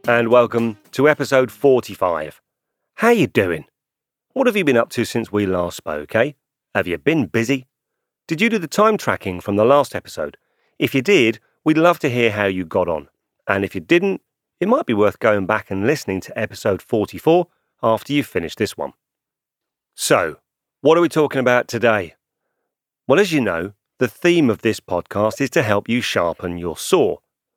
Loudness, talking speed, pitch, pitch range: -18 LUFS, 190 wpm, 120 Hz, 100-145 Hz